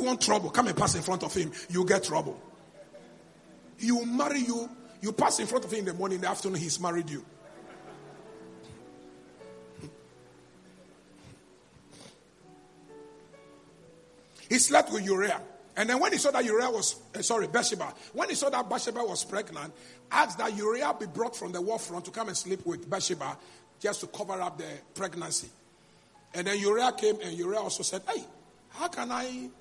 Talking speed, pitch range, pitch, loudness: 175 wpm, 170-235 Hz, 195 Hz, -29 LUFS